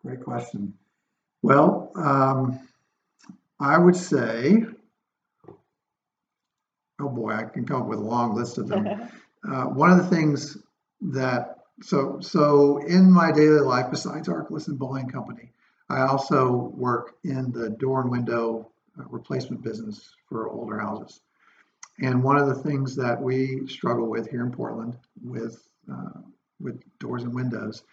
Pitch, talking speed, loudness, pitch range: 130 Hz, 145 wpm, -23 LUFS, 120-145 Hz